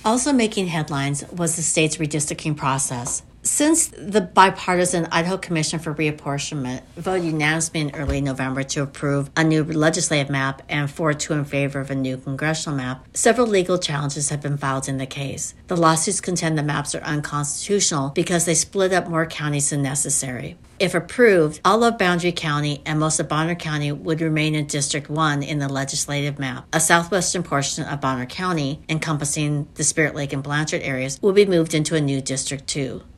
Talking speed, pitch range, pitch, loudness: 185 wpm, 140-170 Hz, 155 Hz, -21 LUFS